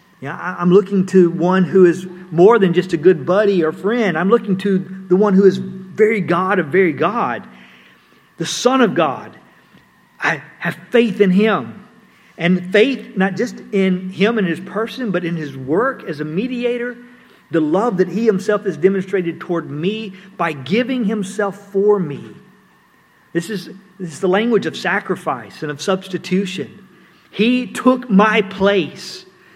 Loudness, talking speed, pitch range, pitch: -17 LUFS, 165 wpm, 180-210 Hz, 190 Hz